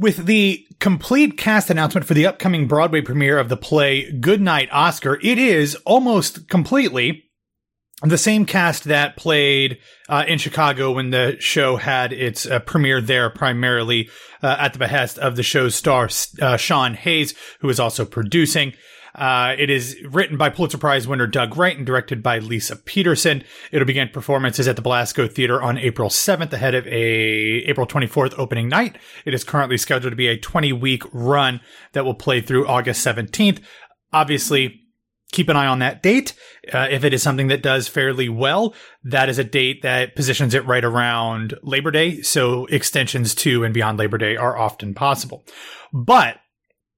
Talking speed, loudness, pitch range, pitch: 175 wpm, -18 LUFS, 125-155 Hz, 135 Hz